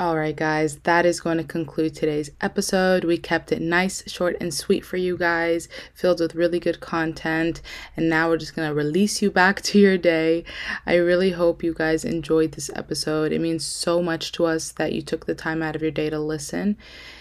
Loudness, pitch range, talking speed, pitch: -22 LUFS, 160-175 Hz, 215 wpm, 165 Hz